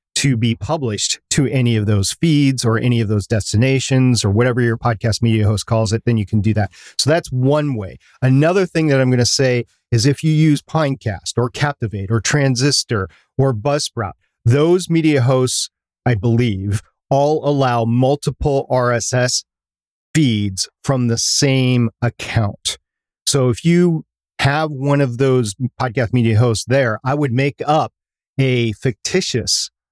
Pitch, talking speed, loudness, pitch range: 125 Hz, 160 wpm, -17 LUFS, 115-140 Hz